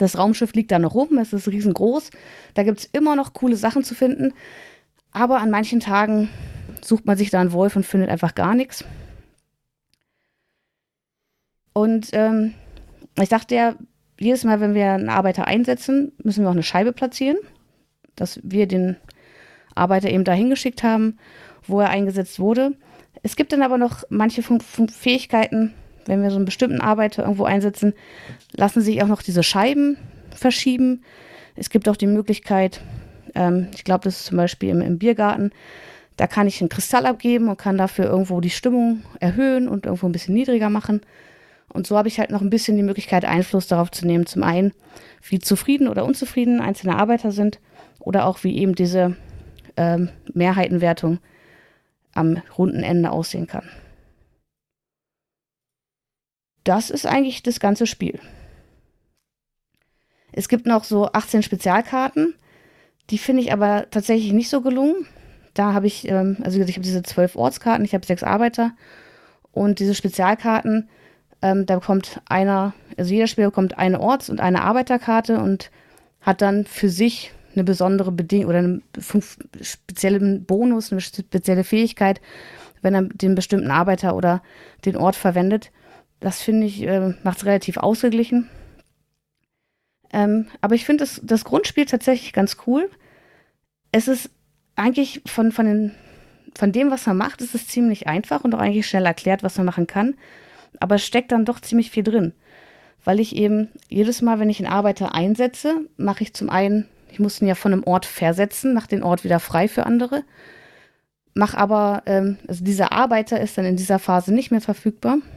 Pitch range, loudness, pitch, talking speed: 190-235 Hz, -20 LUFS, 205 Hz, 170 wpm